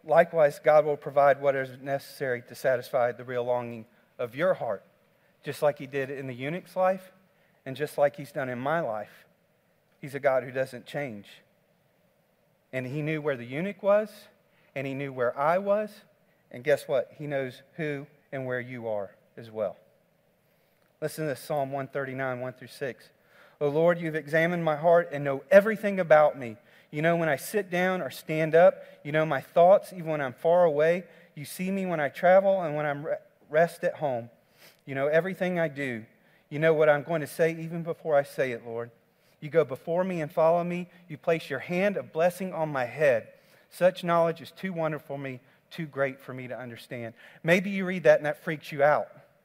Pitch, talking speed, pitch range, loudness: 155 Hz, 200 wpm, 135-180 Hz, -27 LUFS